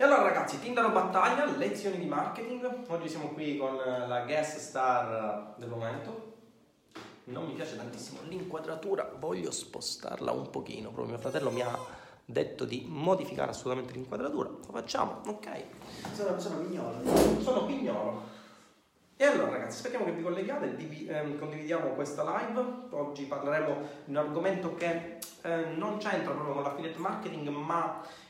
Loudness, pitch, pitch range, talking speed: -33 LUFS, 165 Hz, 145-195 Hz, 145 wpm